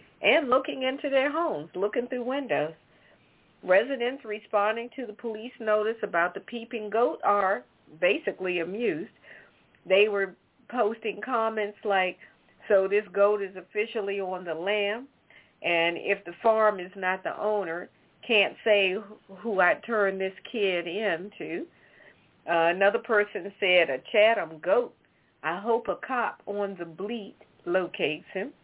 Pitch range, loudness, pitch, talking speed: 185-225 Hz, -27 LUFS, 205 Hz, 140 wpm